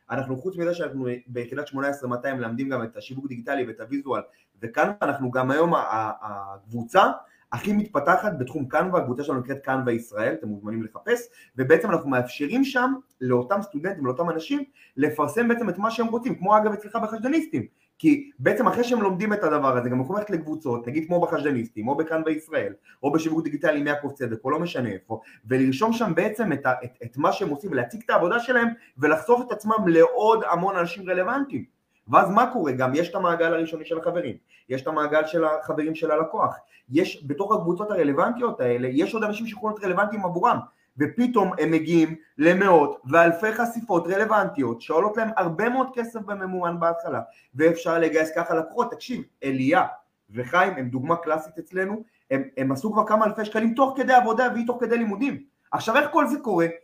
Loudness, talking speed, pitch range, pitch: -24 LUFS, 180 wpm, 135-220 Hz, 170 Hz